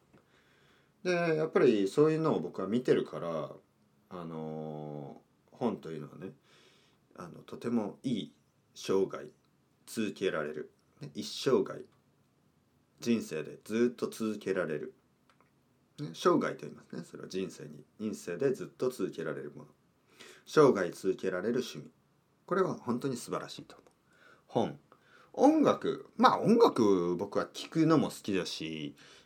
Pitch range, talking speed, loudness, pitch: 85-135 Hz, 255 characters per minute, -32 LUFS, 105 Hz